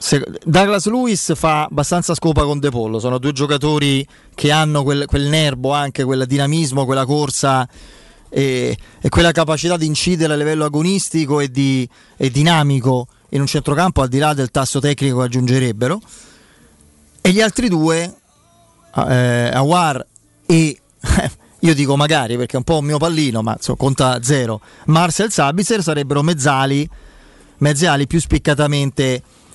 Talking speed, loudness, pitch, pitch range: 145 wpm, -16 LUFS, 145 Hz, 130-160 Hz